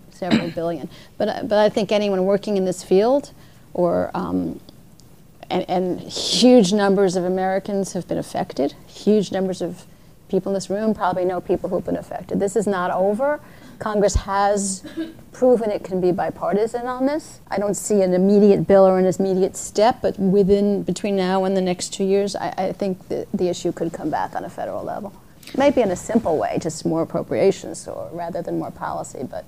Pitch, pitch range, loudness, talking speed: 195 Hz, 180-205 Hz, -21 LUFS, 190 wpm